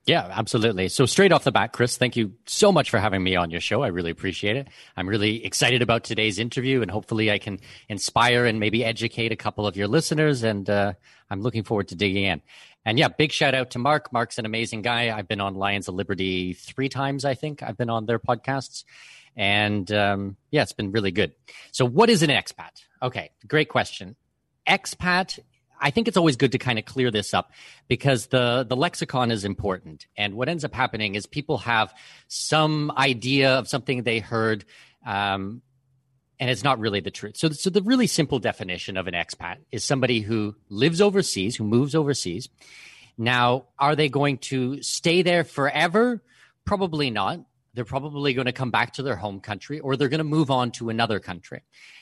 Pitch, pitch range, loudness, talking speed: 120 Hz, 105-140 Hz, -23 LUFS, 200 wpm